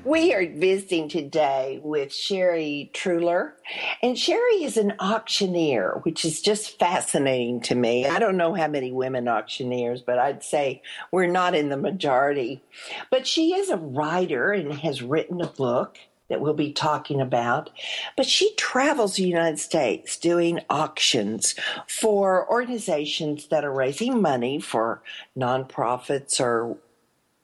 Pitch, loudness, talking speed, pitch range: 160 Hz, -24 LUFS, 140 wpm, 135-205 Hz